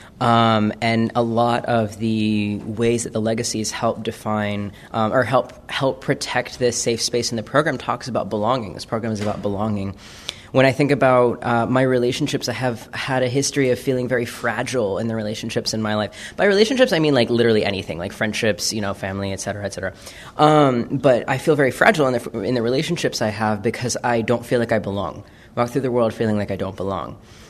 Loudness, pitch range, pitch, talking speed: -20 LUFS, 105-125 Hz, 115 Hz, 215 wpm